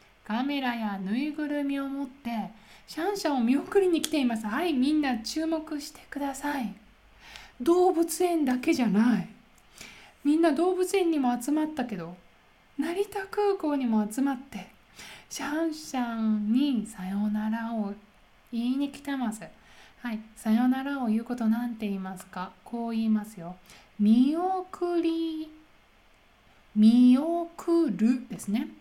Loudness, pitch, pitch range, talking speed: -28 LUFS, 255 Hz, 220-310 Hz, 270 characters per minute